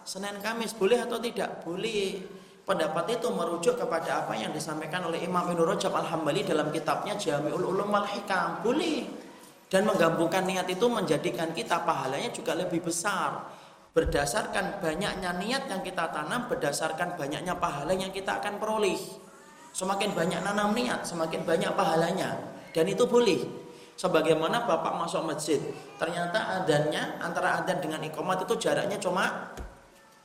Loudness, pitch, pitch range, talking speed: -29 LUFS, 185 Hz, 165-205 Hz, 140 wpm